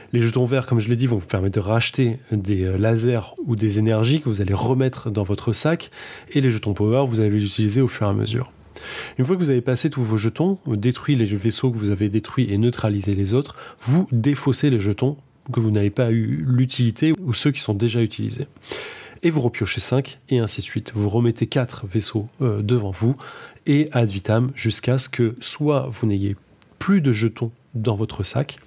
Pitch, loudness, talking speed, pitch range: 120 Hz, -21 LUFS, 215 wpm, 110-130 Hz